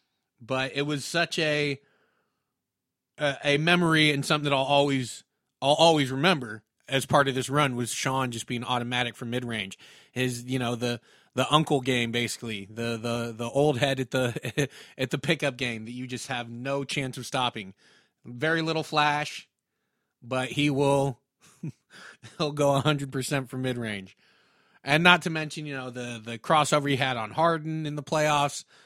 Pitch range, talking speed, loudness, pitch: 125-150 Hz, 170 wpm, -26 LUFS, 135 Hz